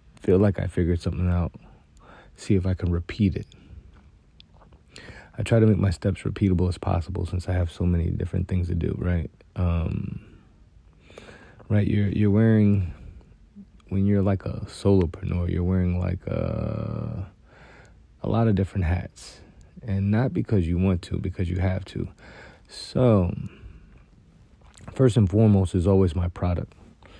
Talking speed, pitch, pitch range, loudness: 150 wpm, 95 Hz, 90-105 Hz, -24 LUFS